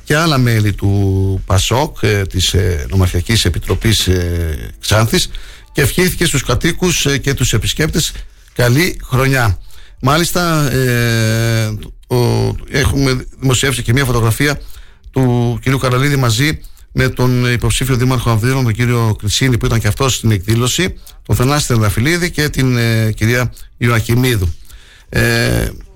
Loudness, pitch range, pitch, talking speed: -14 LUFS, 105-135 Hz, 120 Hz, 145 wpm